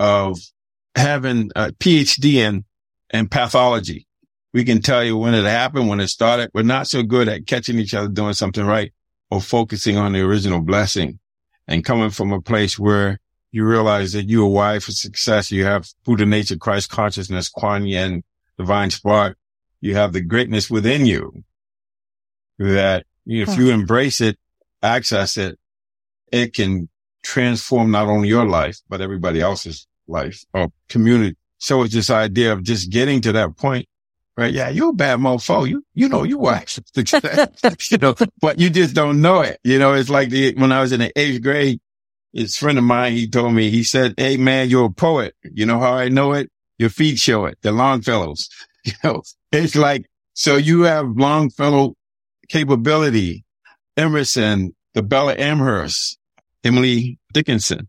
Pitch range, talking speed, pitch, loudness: 100-130 Hz, 175 wpm, 110 Hz, -17 LUFS